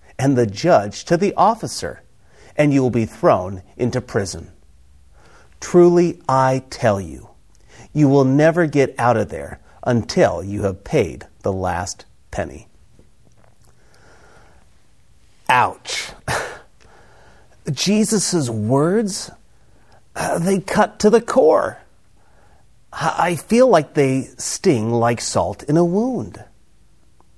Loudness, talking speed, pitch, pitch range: -18 LUFS, 110 wpm, 130 Hz, 100-170 Hz